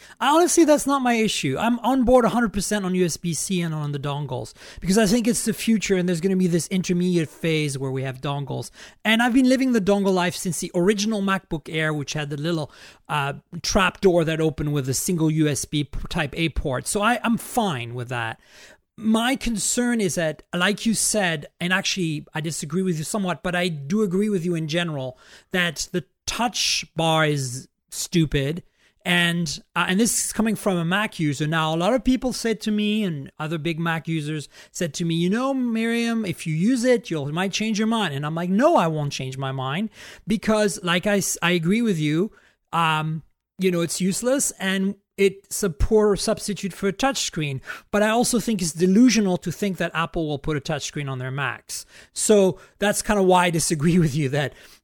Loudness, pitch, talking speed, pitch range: -22 LUFS, 180 Hz, 210 wpm, 160-215 Hz